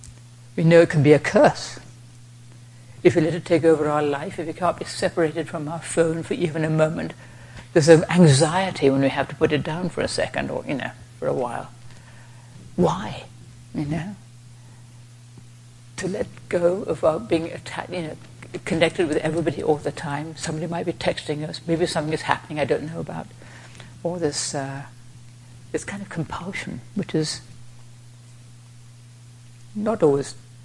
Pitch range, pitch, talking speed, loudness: 120-165 Hz, 145 Hz, 170 wpm, -22 LUFS